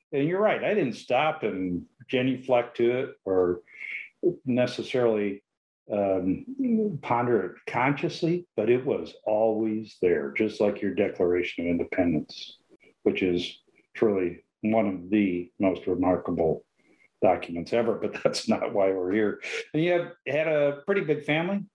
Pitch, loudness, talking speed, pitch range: 115 Hz, -27 LUFS, 140 wpm, 95-150 Hz